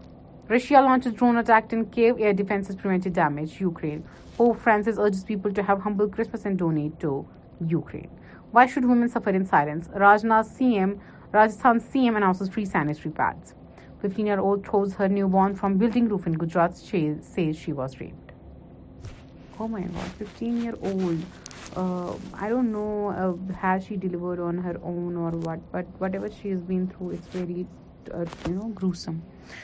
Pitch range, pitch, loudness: 175-215 Hz, 195 Hz, -25 LUFS